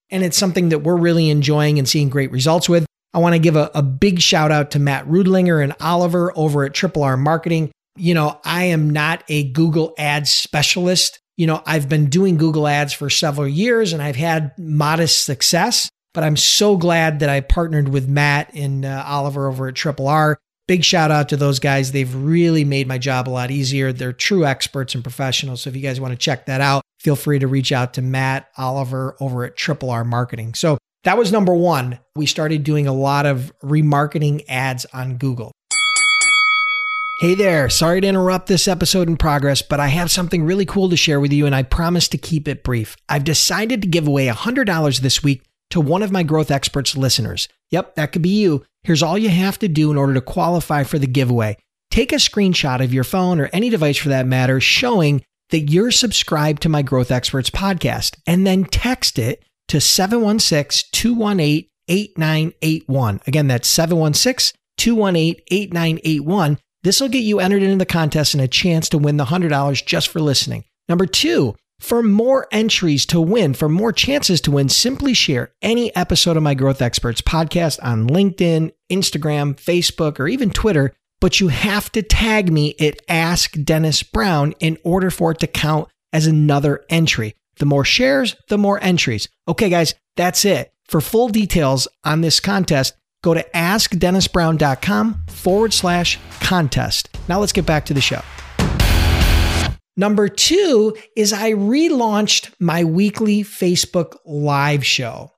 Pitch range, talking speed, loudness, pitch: 140-185 Hz, 185 wpm, -17 LUFS, 160 Hz